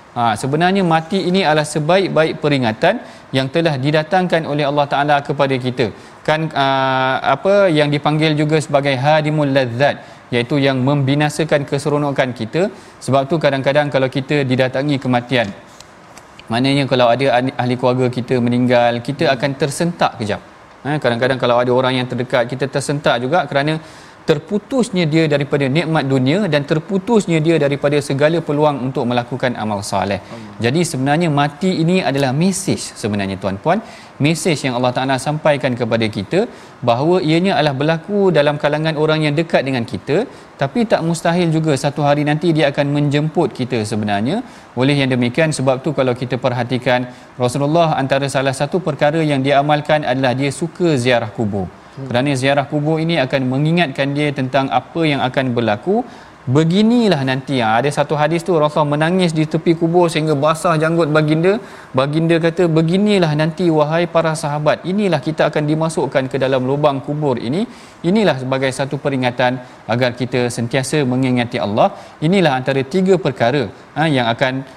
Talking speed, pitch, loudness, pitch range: 150 wpm, 145 Hz, -16 LUFS, 130-160 Hz